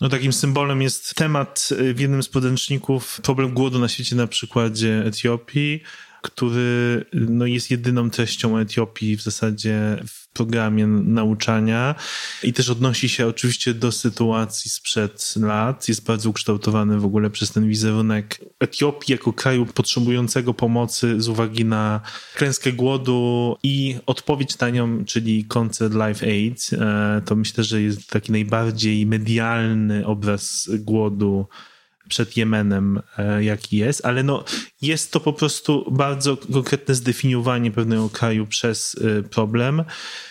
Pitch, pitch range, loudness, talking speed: 115 Hz, 110-130 Hz, -21 LUFS, 130 wpm